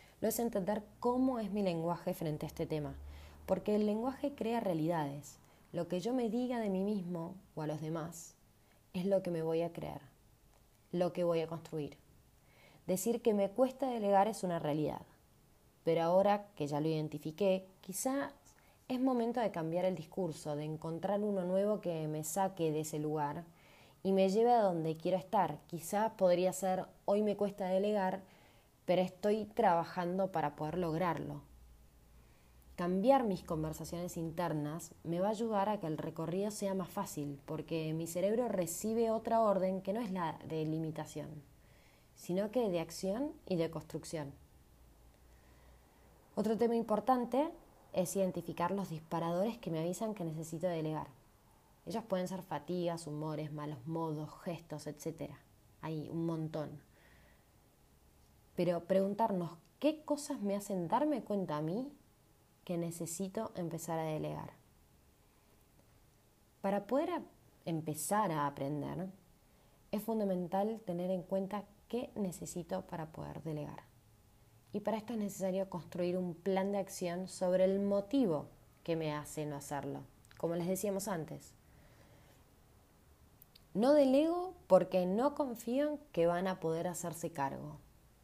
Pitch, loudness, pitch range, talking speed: 175 Hz, -36 LUFS, 150-200 Hz, 145 wpm